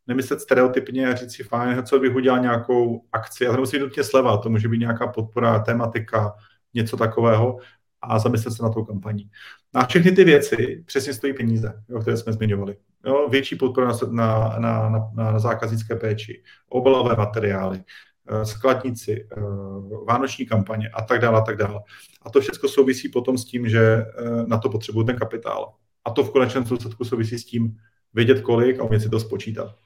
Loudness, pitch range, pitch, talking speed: -21 LUFS, 110-130 Hz, 115 Hz, 175 wpm